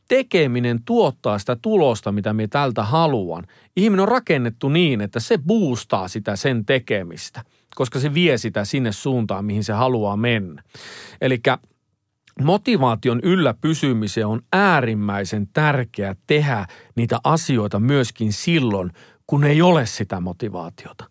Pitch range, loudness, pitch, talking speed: 105-155 Hz, -20 LUFS, 120 Hz, 130 wpm